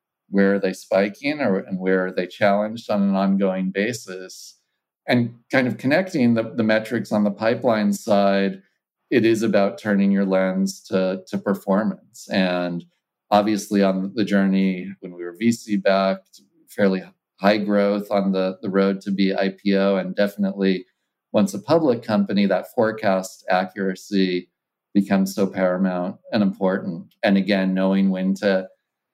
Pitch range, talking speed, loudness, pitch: 95-100 Hz, 150 wpm, -21 LUFS, 100 Hz